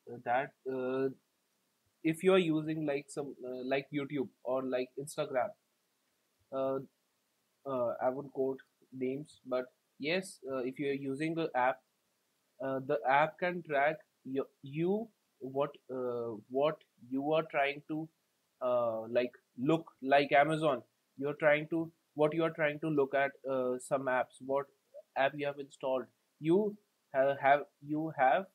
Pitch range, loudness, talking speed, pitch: 130-155 Hz, -34 LUFS, 155 wpm, 140 Hz